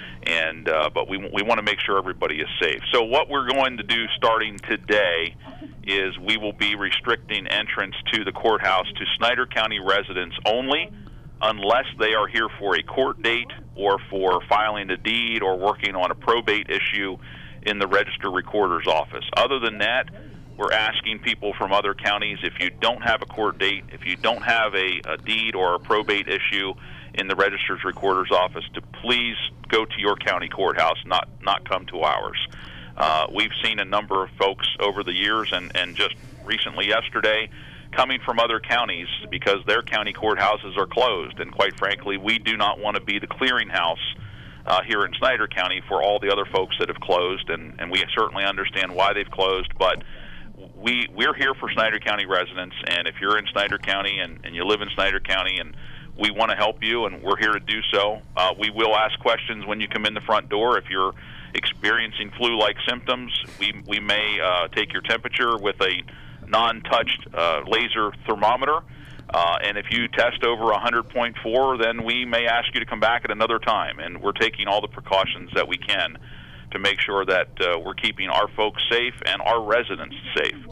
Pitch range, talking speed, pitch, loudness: 95-115 Hz, 195 wpm, 105 Hz, -22 LUFS